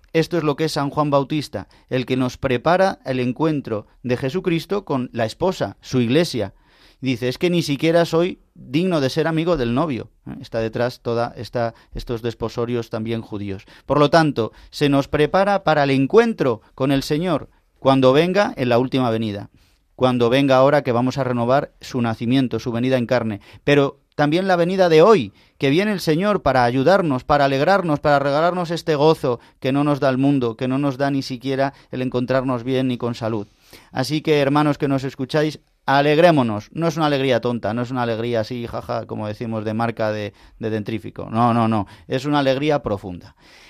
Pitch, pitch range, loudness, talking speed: 130 Hz, 120-150 Hz, -20 LUFS, 190 wpm